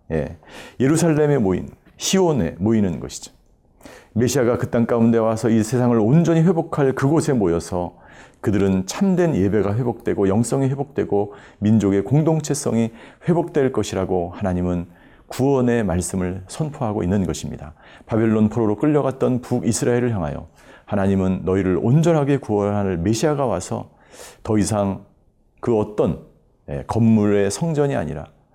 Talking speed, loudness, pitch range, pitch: 320 characters per minute, -20 LUFS, 100-140 Hz, 115 Hz